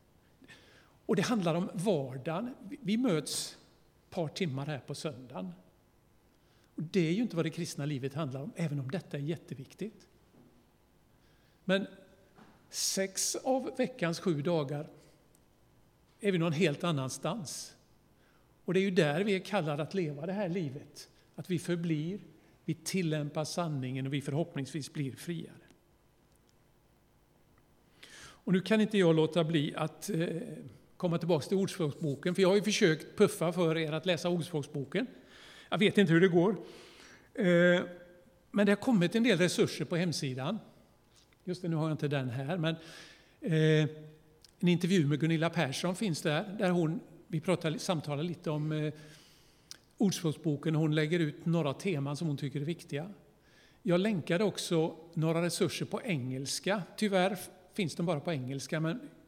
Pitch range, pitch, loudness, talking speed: 155-190 Hz, 165 Hz, -32 LUFS, 150 wpm